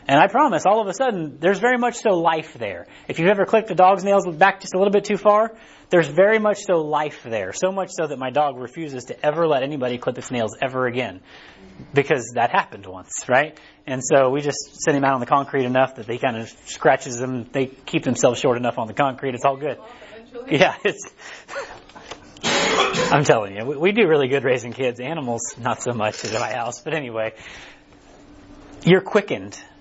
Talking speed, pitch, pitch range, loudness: 210 wpm, 145 Hz, 125-185 Hz, -20 LUFS